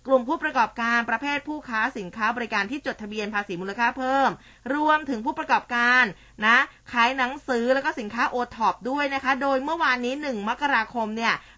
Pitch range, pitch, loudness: 225-275 Hz, 245 Hz, -24 LUFS